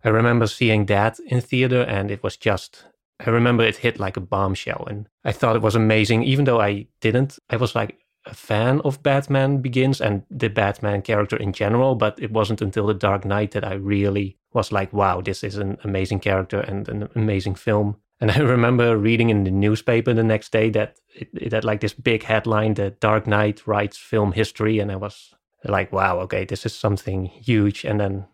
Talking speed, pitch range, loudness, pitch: 210 wpm, 100-115 Hz, -21 LUFS, 110 Hz